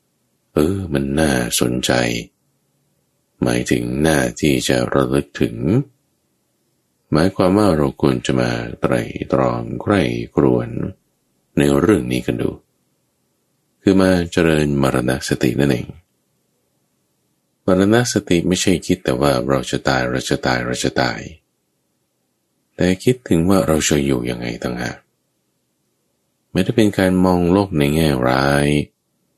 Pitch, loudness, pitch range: 70 Hz, -18 LUFS, 65-90 Hz